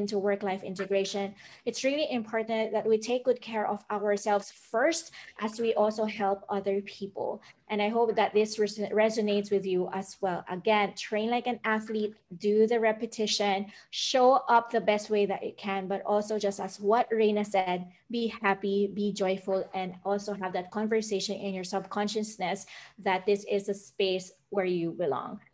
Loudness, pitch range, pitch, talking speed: -29 LUFS, 195-220 Hz, 205 Hz, 170 wpm